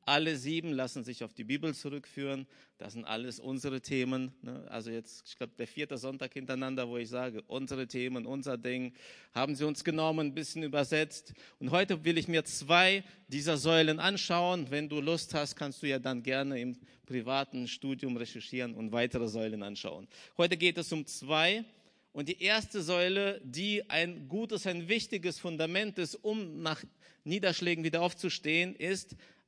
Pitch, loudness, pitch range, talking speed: 150 Hz, -33 LUFS, 130-175 Hz, 170 wpm